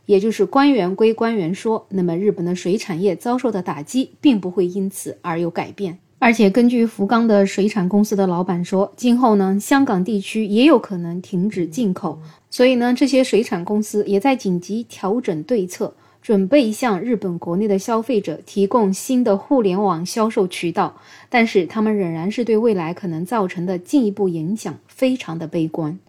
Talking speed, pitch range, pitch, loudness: 290 characters per minute, 185-230 Hz, 200 Hz, -19 LUFS